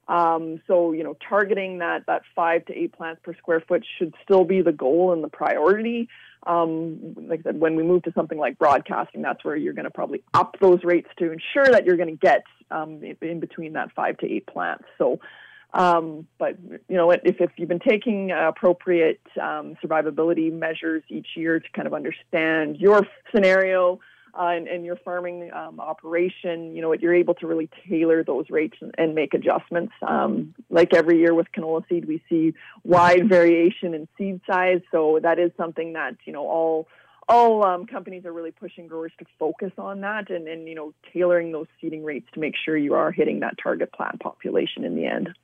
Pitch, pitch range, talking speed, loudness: 170 Hz, 160-180 Hz, 205 wpm, -22 LUFS